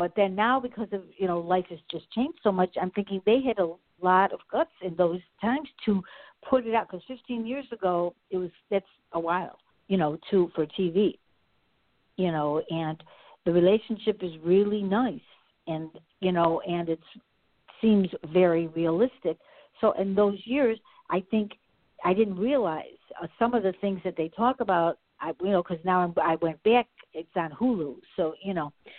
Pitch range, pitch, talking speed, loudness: 170-225 Hz, 190 Hz, 190 wpm, -27 LUFS